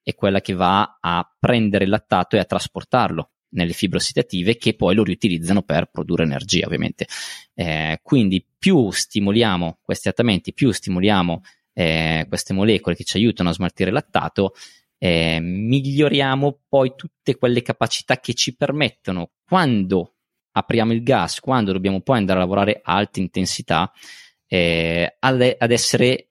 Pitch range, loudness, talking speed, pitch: 90-120 Hz, -20 LUFS, 150 wpm, 100 Hz